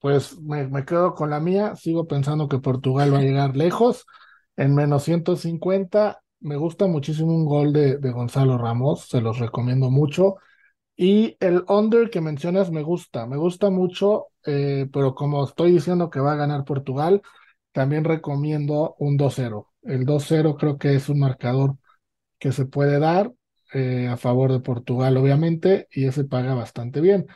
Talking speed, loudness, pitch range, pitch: 170 wpm, -21 LUFS, 135-175 Hz, 145 Hz